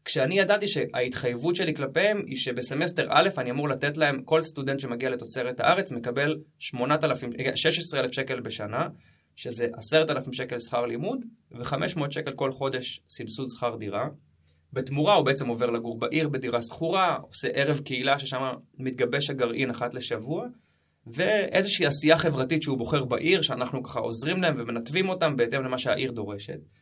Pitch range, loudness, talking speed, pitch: 125-155 Hz, -27 LUFS, 145 wpm, 135 Hz